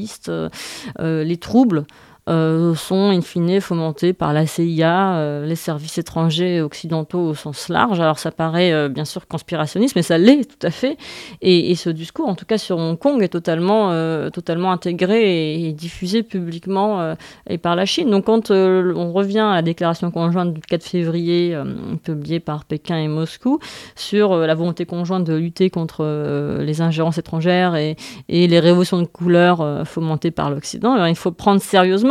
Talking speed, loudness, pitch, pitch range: 190 wpm, -18 LUFS, 170 Hz, 160-185 Hz